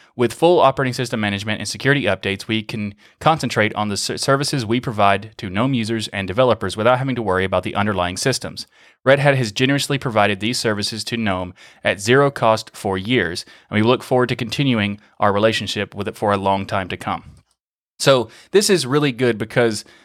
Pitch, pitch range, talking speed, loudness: 110 Hz, 100-130 Hz, 195 wpm, -19 LUFS